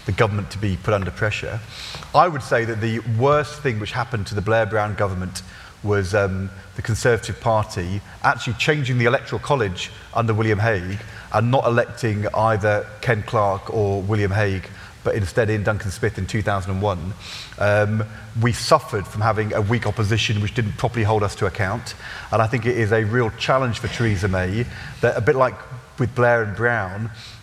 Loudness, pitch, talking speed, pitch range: -21 LUFS, 110 Hz, 185 wpm, 105-120 Hz